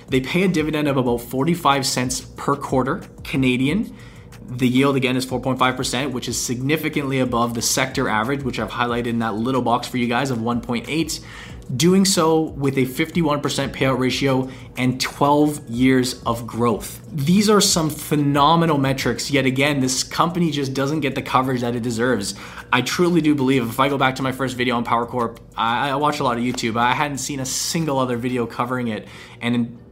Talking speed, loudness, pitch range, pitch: 195 wpm, -20 LUFS, 120-145 Hz, 130 Hz